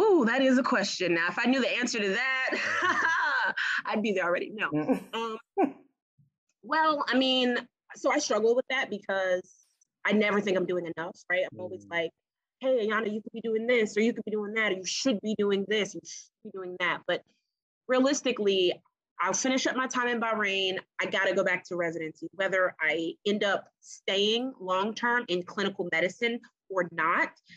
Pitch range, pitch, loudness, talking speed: 185-250 Hz, 210 Hz, -28 LUFS, 195 wpm